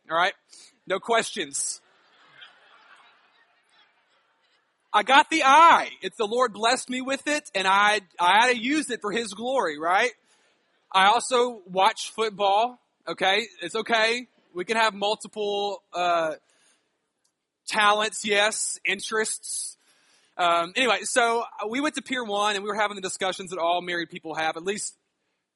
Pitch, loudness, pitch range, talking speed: 210 Hz, -23 LUFS, 190-235 Hz, 145 wpm